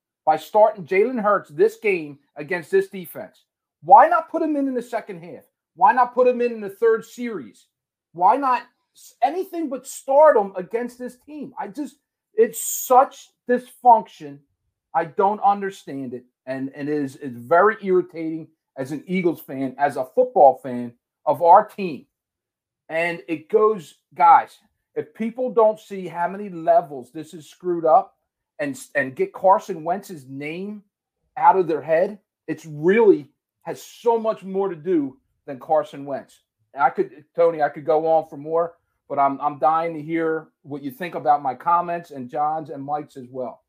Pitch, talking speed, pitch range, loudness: 180 Hz, 175 wpm, 150-240 Hz, -21 LUFS